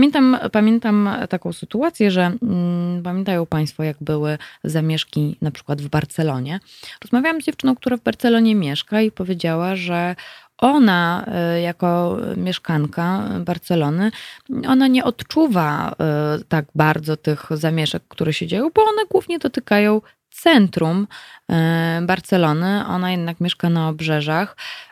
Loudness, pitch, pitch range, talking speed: -19 LUFS, 180 Hz, 160-225 Hz, 120 wpm